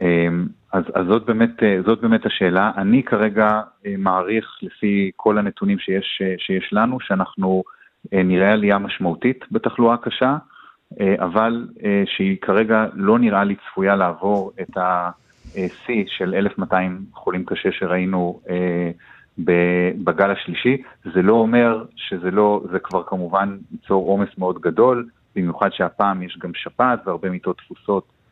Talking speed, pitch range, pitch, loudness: 125 wpm, 95-110 Hz, 100 Hz, -20 LUFS